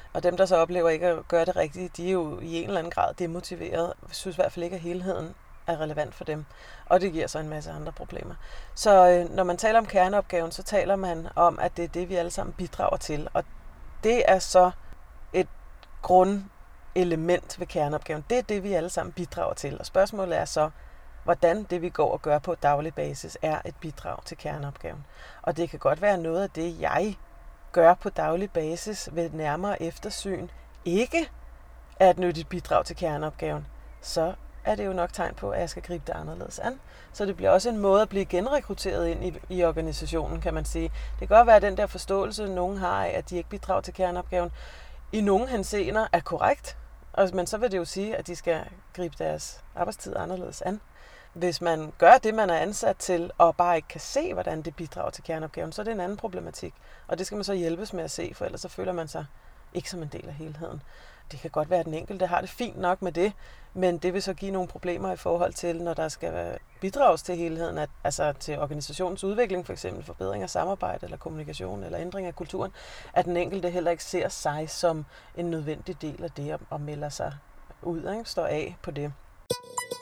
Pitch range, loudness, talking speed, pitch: 160-185 Hz, -27 LUFS, 220 wpm, 175 Hz